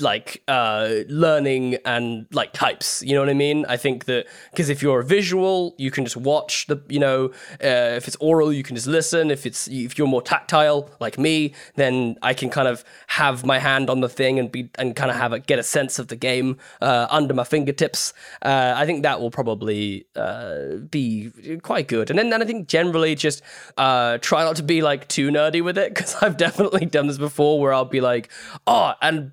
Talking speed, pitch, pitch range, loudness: 225 wpm, 140 Hz, 125-155 Hz, -21 LUFS